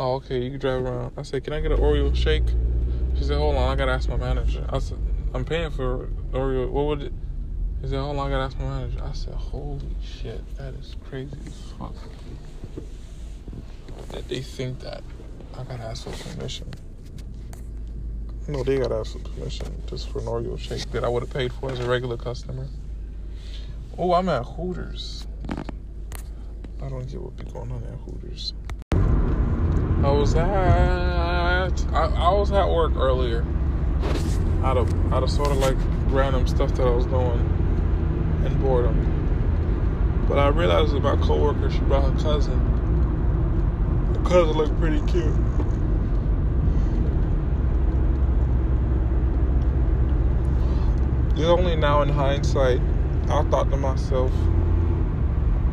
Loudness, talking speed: -24 LUFS, 150 wpm